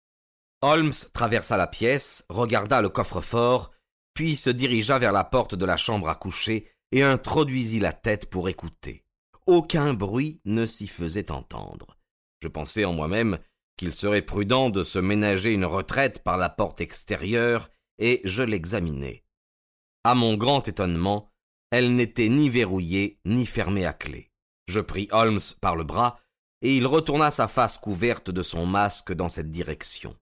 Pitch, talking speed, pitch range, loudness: 105 Hz, 155 wpm, 90-120 Hz, -24 LUFS